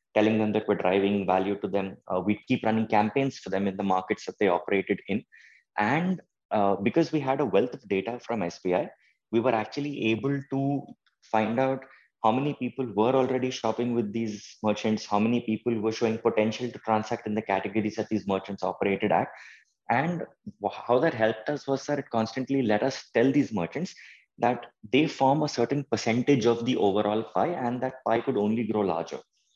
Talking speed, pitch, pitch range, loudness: 195 wpm, 115 Hz, 105-130 Hz, -27 LUFS